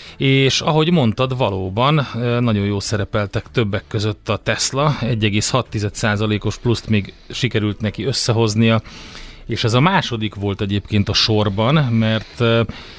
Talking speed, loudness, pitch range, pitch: 120 wpm, -18 LUFS, 105-125 Hz, 110 Hz